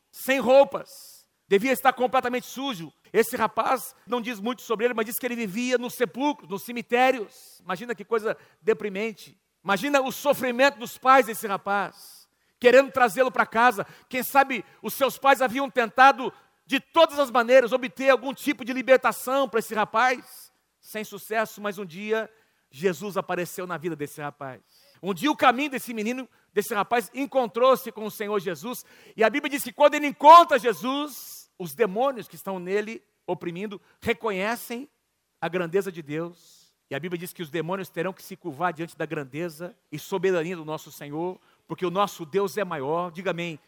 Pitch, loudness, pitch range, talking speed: 225 Hz, -24 LUFS, 185-255 Hz, 175 wpm